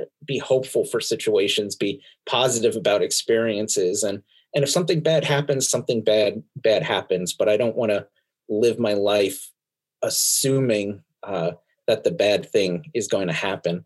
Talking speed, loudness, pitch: 155 wpm, -22 LUFS, 145 Hz